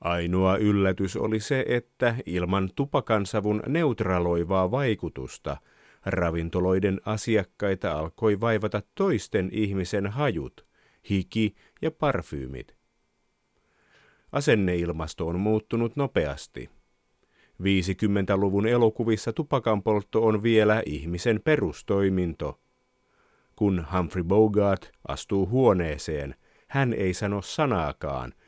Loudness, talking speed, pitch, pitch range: -26 LUFS, 85 wpm, 100 Hz, 90-110 Hz